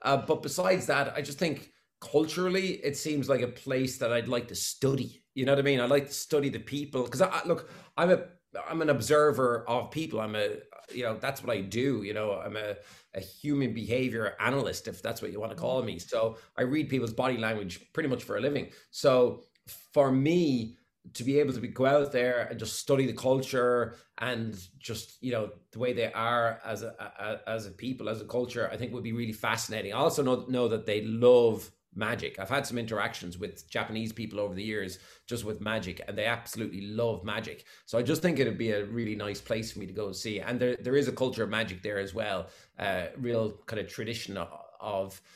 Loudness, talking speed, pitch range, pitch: -30 LUFS, 230 wpm, 110-135 Hz, 120 Hz